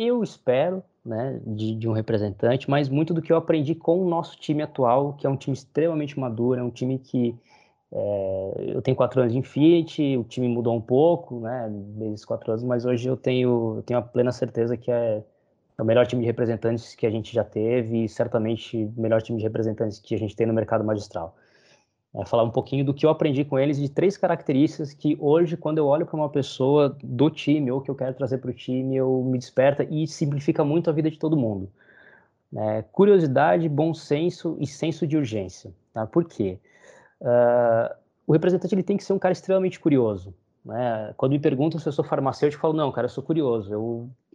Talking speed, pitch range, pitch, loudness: 215 wpm, 115-155 Hz, 130 Hz, -24 LUFS